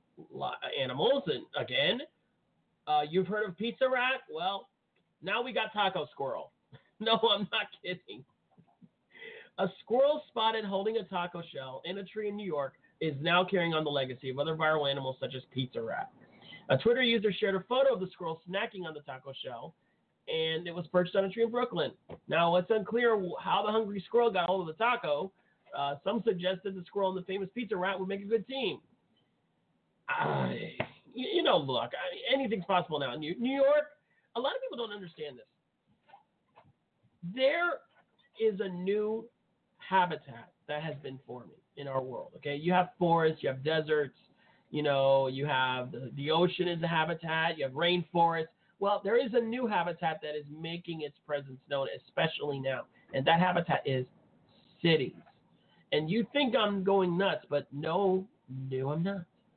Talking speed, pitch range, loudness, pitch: 180 wpm, 150-215 Hz, -32 LUFS, 180 Hz